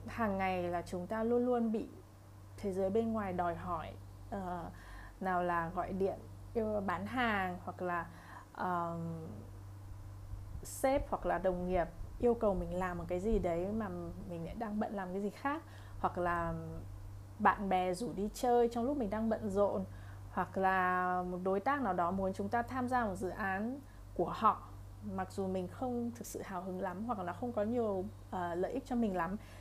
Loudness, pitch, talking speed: -36 LUFS, 180 Hz, 195 wpm